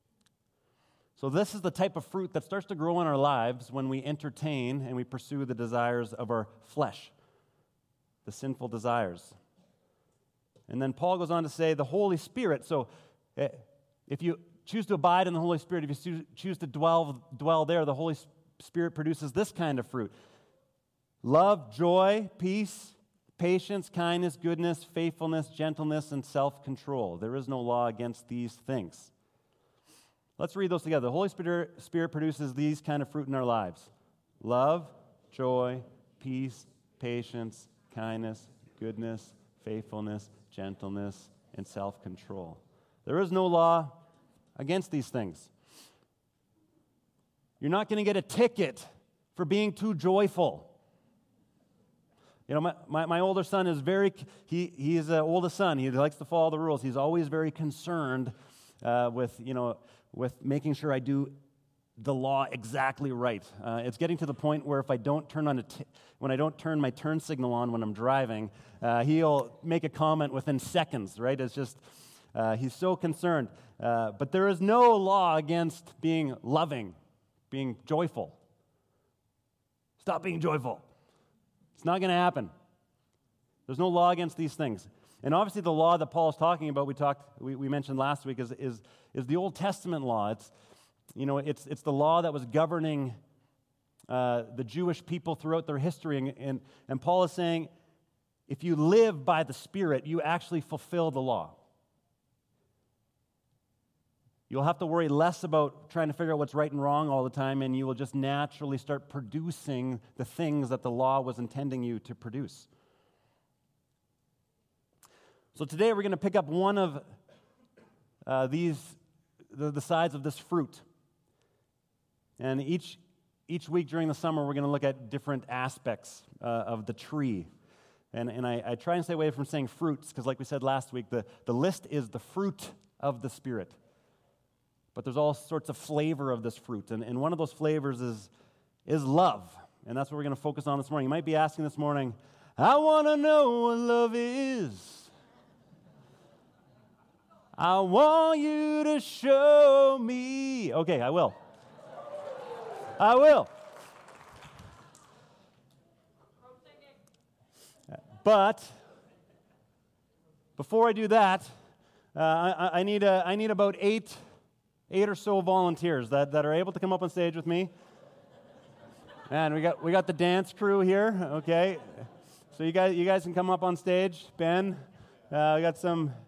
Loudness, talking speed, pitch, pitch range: -30 LUFS, 165 wpm, 150 Hz, 130-175 Hz